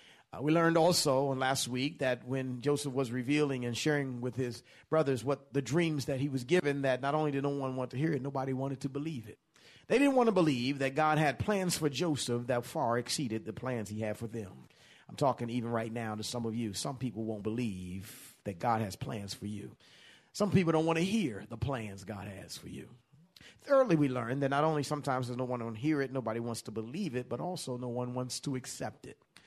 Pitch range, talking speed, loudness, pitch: 120-150 Hz, 235 wpm, -33 LUFS, 130 Hz